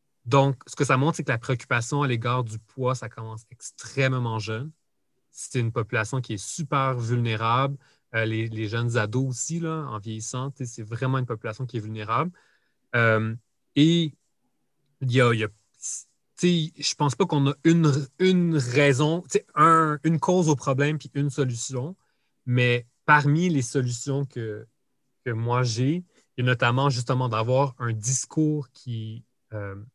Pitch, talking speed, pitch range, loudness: 130 Hz, 160 wpm, 120-145 Hz, -25 LUFS